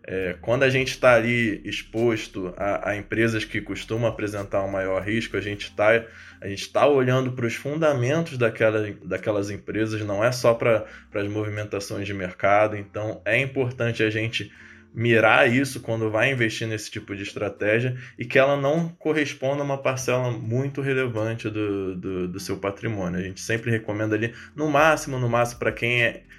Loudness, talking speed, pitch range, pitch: -24 LUFS, 175 wpm, 105-125 Hz, 110 Hz